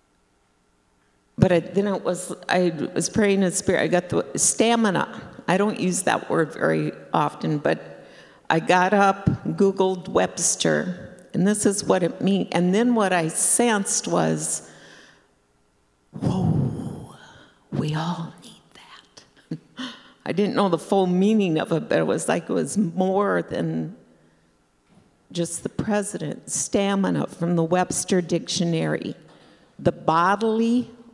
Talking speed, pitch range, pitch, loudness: 135 wpm, 130-200 Hz, 180 Hz, -22 LUFS